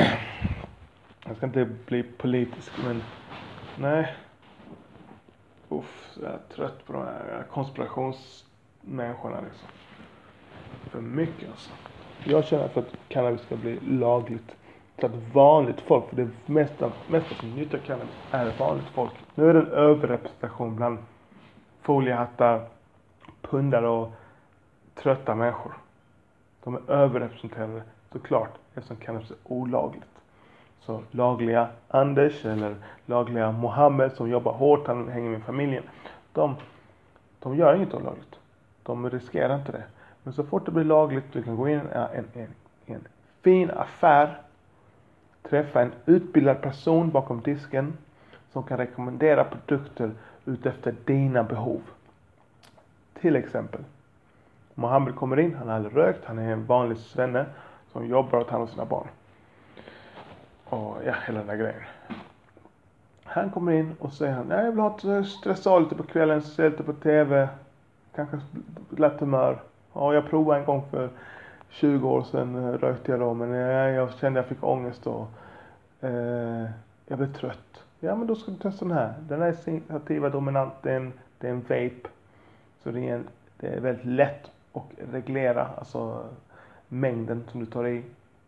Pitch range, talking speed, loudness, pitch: 115-145 Hz, 145 wpm, -26 LUFS, 125 Hz